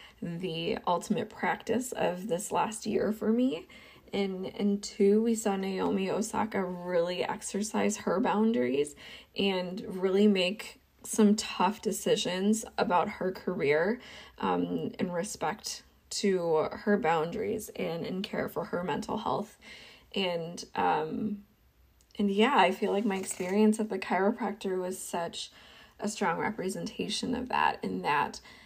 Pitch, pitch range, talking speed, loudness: 205 Hz, 185-220 Hz, 130 wpm, -30 LUFS